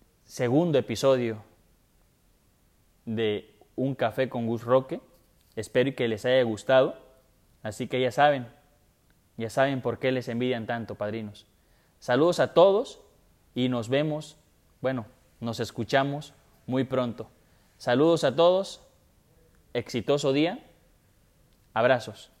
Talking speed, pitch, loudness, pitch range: 115 wpm, 125 Hz, -26 LUFS, 115-135 Hz